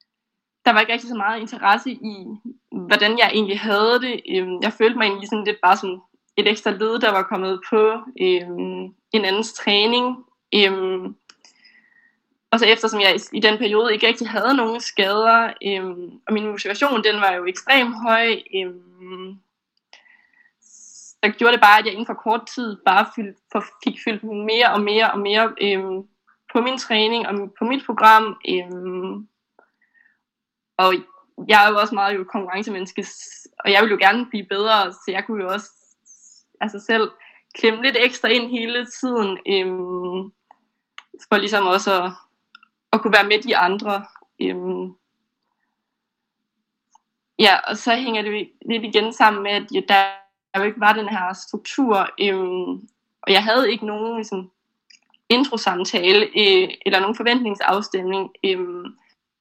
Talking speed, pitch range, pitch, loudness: 155 wpm, 195-235 Hz, 215 Hz, -19 LUFS